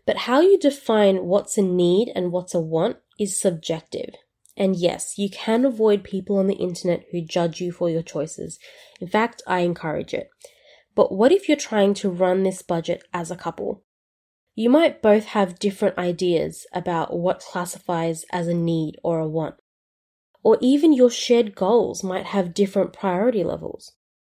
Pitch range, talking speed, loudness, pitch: 175-215 Hz, 175 wpm, -22 LUFS, 190 Hz